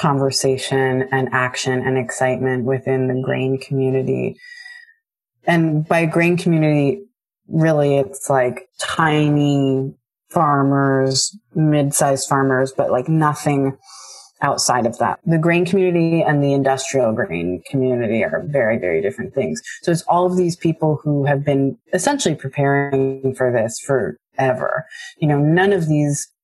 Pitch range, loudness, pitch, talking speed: 135-165 Hz, -18 LUFS, 140 Hz, 135 wpm